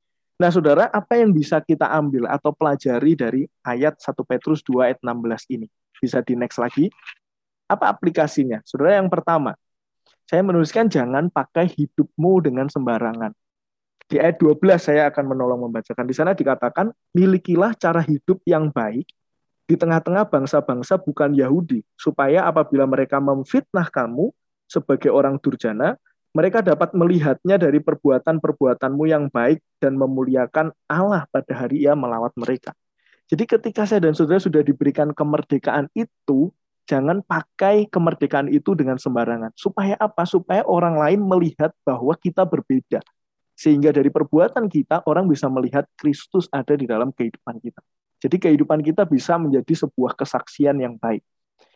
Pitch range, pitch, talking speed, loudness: 135-170 Hz, 150 Hz, 140 wpm, -20 LUFS